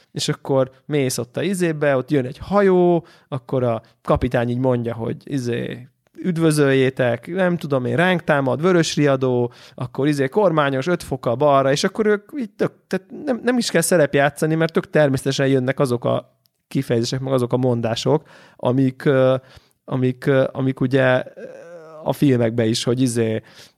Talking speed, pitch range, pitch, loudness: 160 wpm, 125-165 Hz, 135 Hz, -20 LUFS